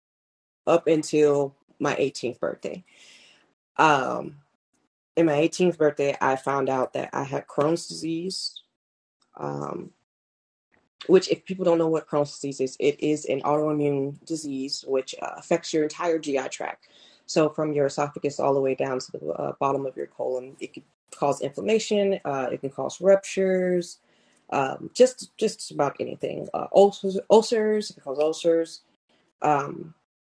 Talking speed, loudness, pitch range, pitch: 160 wpm, -25 LUFS, 140-180 Hz, 155 Hz